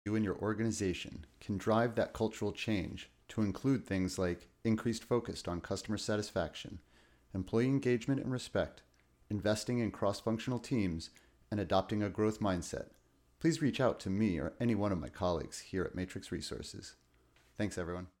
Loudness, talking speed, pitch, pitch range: -36 LUFS, 160 wpm, 105 Hz, 90-110 Hz